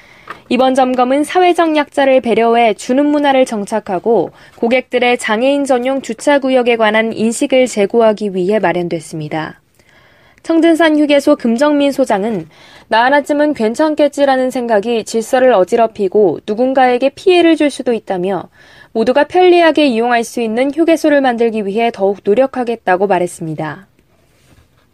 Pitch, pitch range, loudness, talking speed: 245 Hz, 215-285 Hz, -13 LUFS, 330 characters per minute